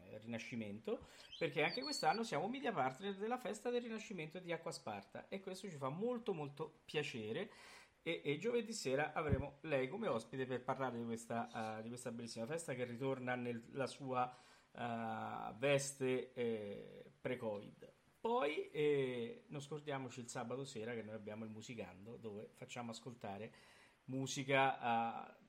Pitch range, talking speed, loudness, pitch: 115-155 Hz, 150 wpm, -43 LUFS, 130 Hz